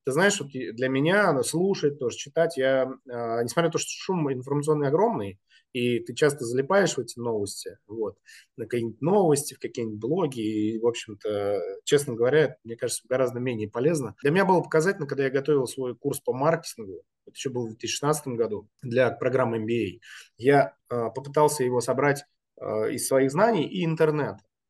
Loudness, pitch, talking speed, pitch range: -26 LUFS, 135 Hz, 175 wpm, 120-155 Hz